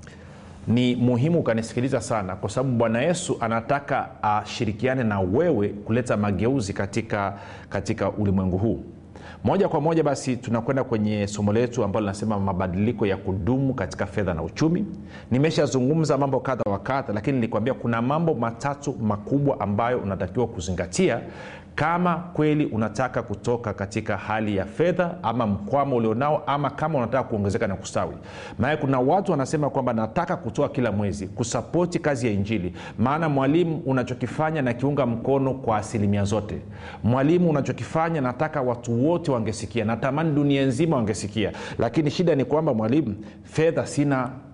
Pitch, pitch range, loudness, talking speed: 120 Hz, 105-140 Hz, -24 LUFS, 140 wpm